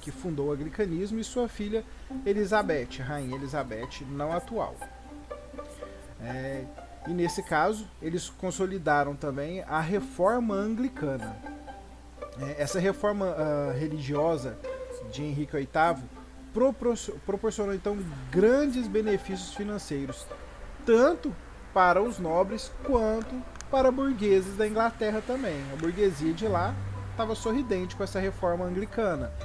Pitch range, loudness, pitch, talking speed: 145-220 Hz, -29 LUFS, 190 Hz, 115 wpm